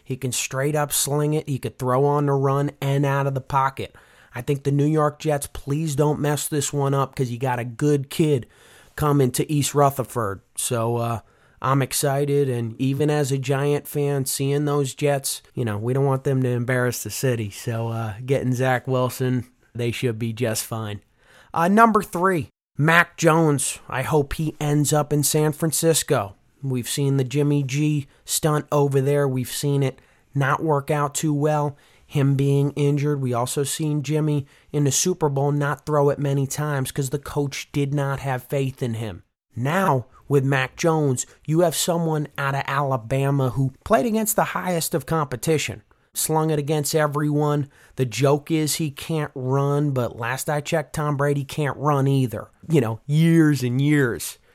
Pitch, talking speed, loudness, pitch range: 140 Hz, 185 wpm, -22 LUFS, 130-150 Hz